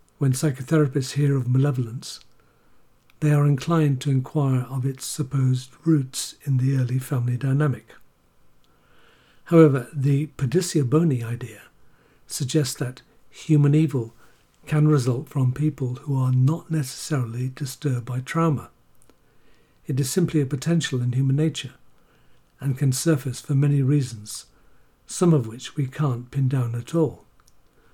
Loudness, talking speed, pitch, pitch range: -23 LUFS, 135 wpm, 140 Hz, 130-150 Hz